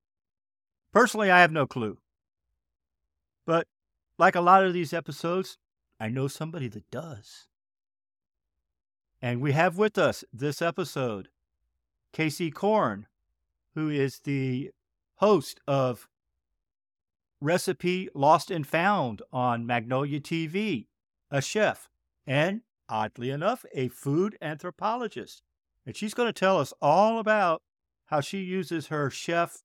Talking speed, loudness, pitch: 120 wpm, -27 LUFS, 145 Hz